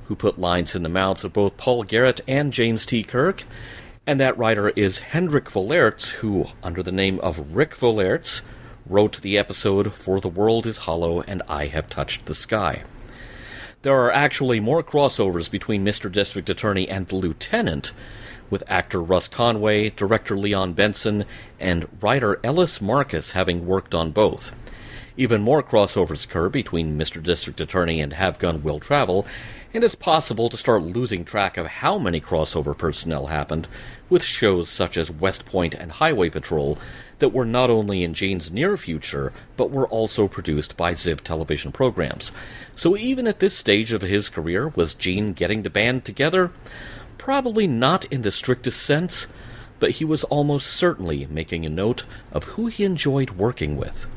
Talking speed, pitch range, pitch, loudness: 170 wpm, 90-125 Hz, 105 Hz, -22 LUFS